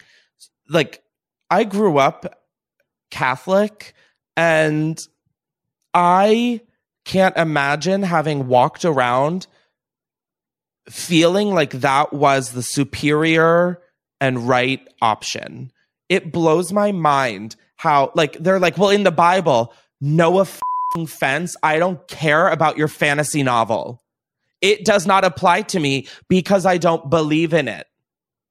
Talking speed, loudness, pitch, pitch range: 115 wpm, -17 LUFS, 165 Hz, 145-185 Hz